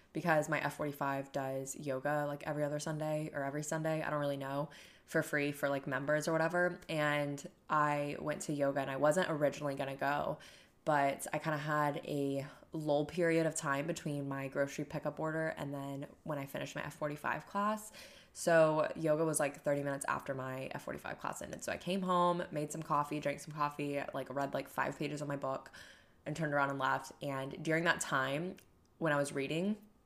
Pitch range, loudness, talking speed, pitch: 140-160 Hz, -36 LUFS, 200 wpm, 150 Hz